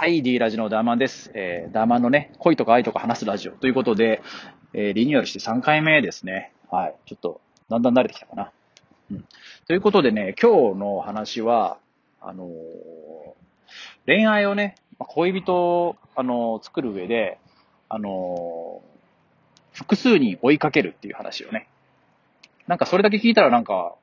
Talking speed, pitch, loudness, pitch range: 330 characters per minute, 135 Hz, -21 LUFS, 110-180 Hz